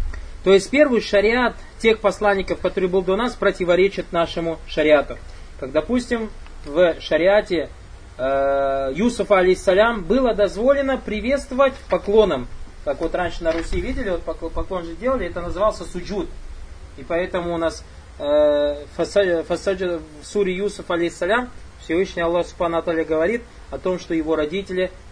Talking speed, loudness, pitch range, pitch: 135 wpm, -20 LUFS, 160-205 Hz, 180 Hz